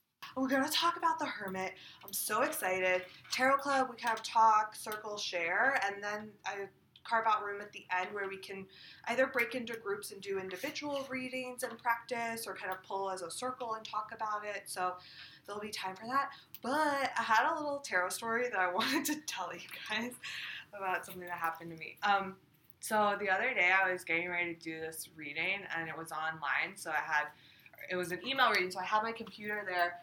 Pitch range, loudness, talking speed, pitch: 180-230 Hz, -34 LUFS, 220 wpm, 200 Hz